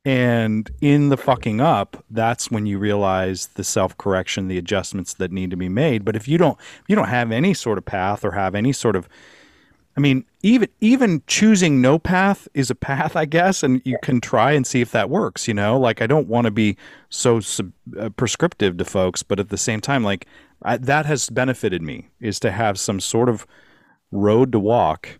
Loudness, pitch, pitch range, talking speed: -19 LUFS, 120 Hz, 100-140 Hz, 215 wpm